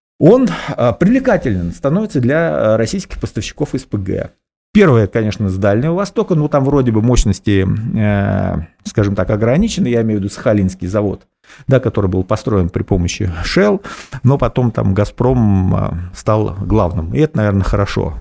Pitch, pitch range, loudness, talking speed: 110 Hz, 100-135 Hz, -15 LUFS, 140 wpm